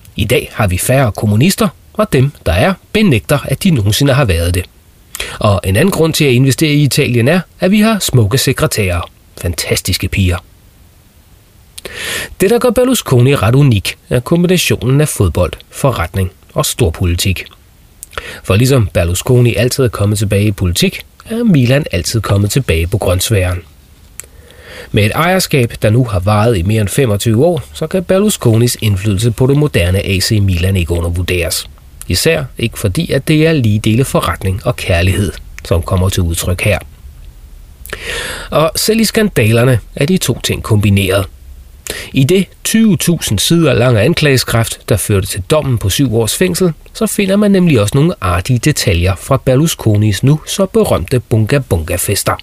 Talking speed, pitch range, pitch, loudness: 160 wpm, 95-140 Hz, 110 Hz, -12 LUFS